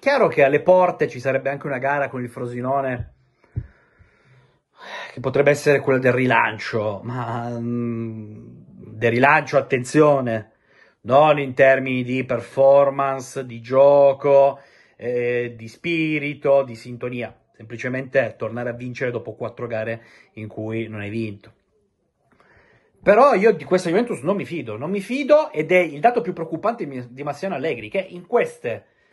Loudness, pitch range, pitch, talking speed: -20 LUFS, 120-145 Hz, 135 Hz, 145 wpm